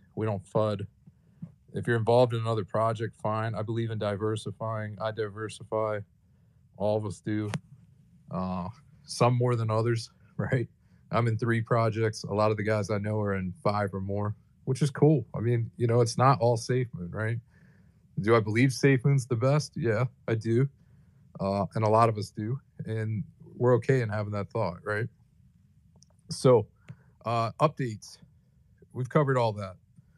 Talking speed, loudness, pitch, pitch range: 175 wpm, -28 LUFS, 115 Hz, 105-125 Hz